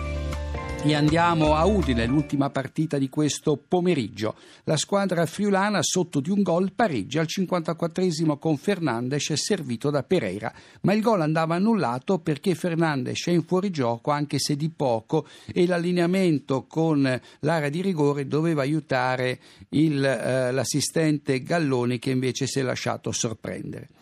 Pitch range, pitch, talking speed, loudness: 135-170 Hz, 150 Hz, 140 wpm, -24 LUFS